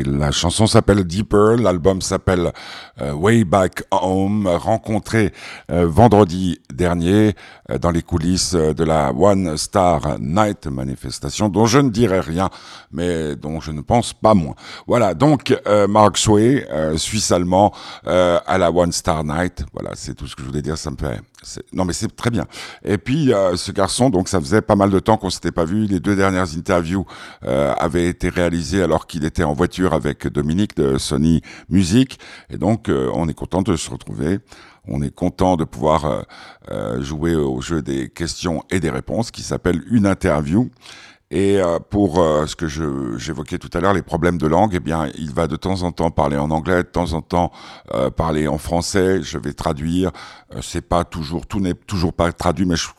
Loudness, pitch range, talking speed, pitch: -18 LUFS, 80-95 Hz, 190 wpm, 90 Hz